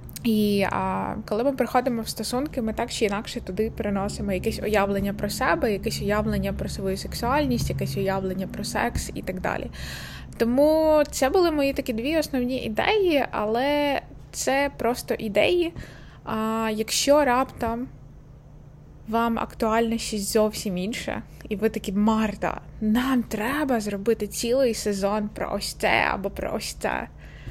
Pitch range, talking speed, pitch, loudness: 205-255 Hz, 140 wpm, 220 Hz, -25 LUFS